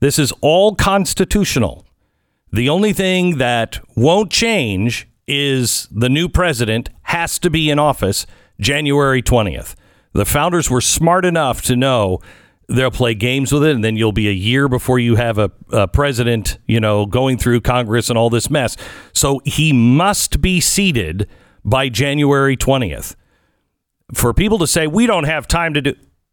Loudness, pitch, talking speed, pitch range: -15 LUFS, 130 Hz, 165 wpm, 115-150 Hz